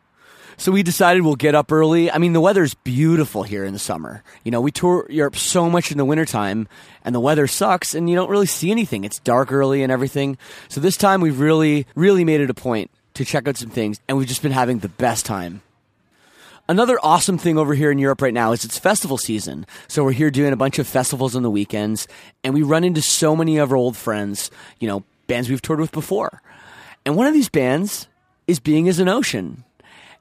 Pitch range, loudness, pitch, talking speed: 120-165 Hz, -18 LUFS, 145 Hz, 230 wpm